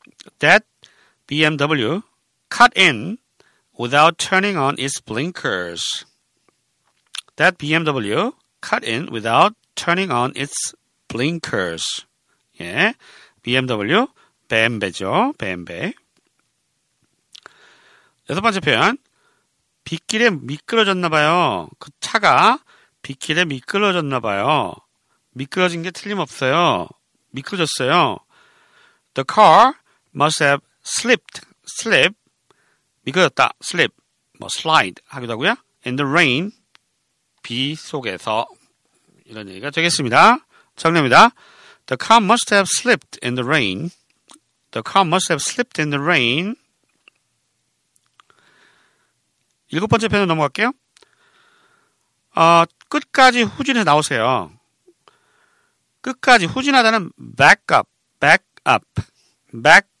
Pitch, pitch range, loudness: 170 Hz, 140-230 Hz, -17 LUFS